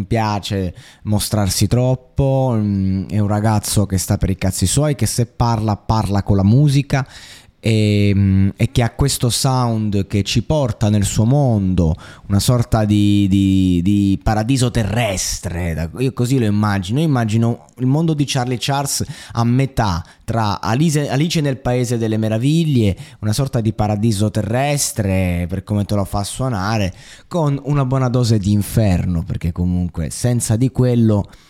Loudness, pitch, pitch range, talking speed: -17 LUFS, 110 Hz, 100-125 Hz, 150 wpm